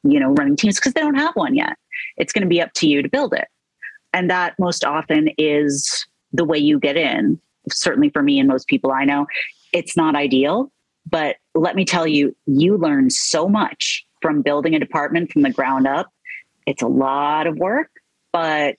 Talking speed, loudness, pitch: 205 wpm, -18 LUFS, 170 Hz